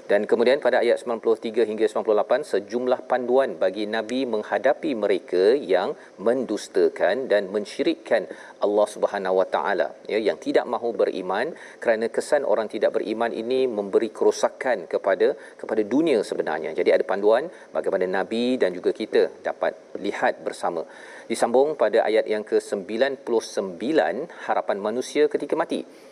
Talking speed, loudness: 130 wpm, -23 LUFS